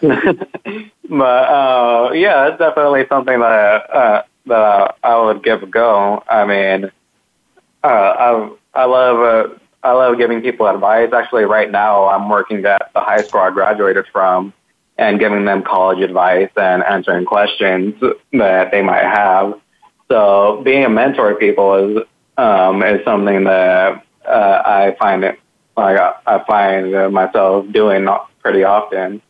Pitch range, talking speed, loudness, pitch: 95-125 Hz, 150 wpm, -13 LUFS, 105 Hz